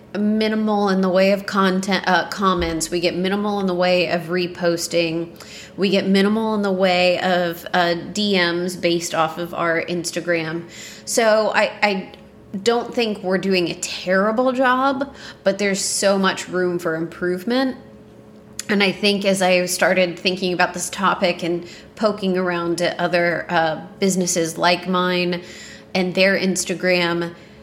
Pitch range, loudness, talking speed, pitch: 175-195 Hz, -19 LUFS, 150 wpm, 185 Hz